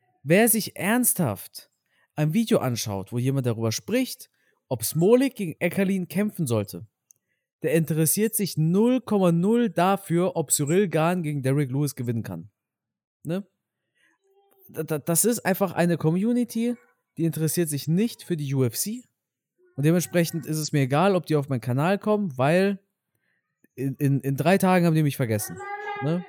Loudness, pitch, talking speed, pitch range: -24 LUFS, 170 Hz, 150 wpm, 140-200 Hz